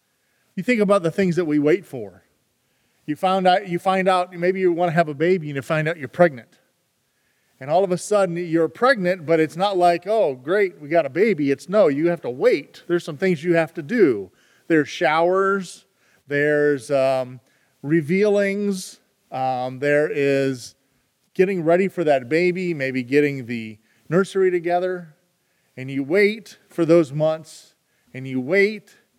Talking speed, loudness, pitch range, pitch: 175 wpm, -20 LUFS, 145-190 Hz, 170 Hz